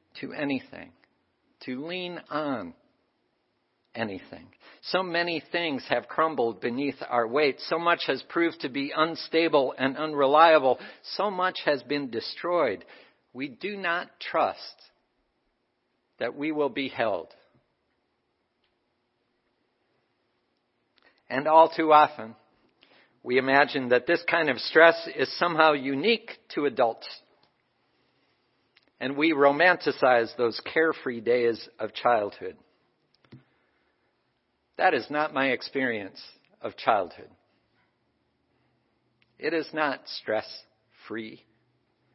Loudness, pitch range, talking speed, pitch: -25 LUFS, 120-165 Hz, 105 wpm, 145 Hz